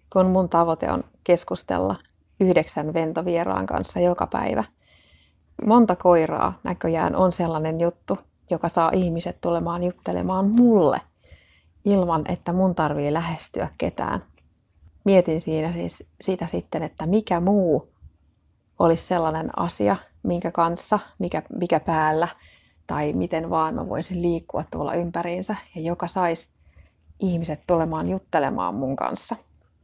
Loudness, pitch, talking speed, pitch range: -23 LUFS, 165 Hz, 120 wpm, 150-180 Hz